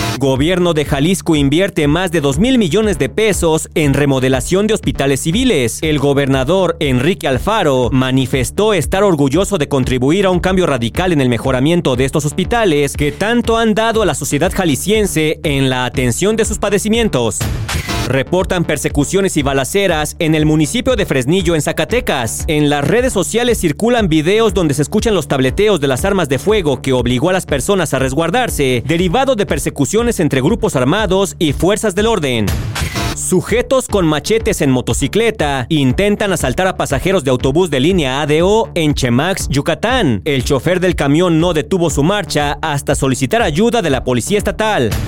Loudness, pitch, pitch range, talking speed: -14 LUFS, 160 Hz, 140-195 Hz, 165 wpm